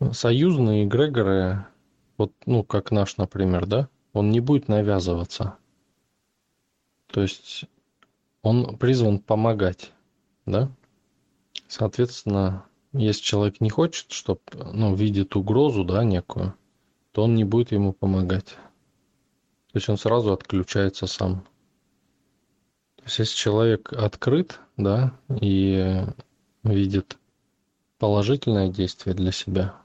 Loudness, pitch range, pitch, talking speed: -24 LUFS, 95-120 Hz, 105 Hz, 105 wpm